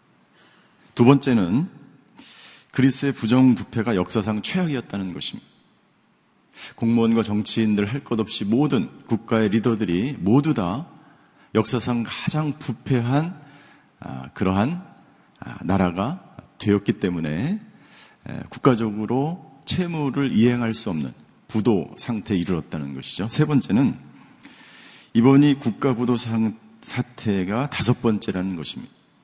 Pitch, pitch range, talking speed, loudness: 115 Hz, 105-140 Hz, 250 characters per minute, -22 LUFS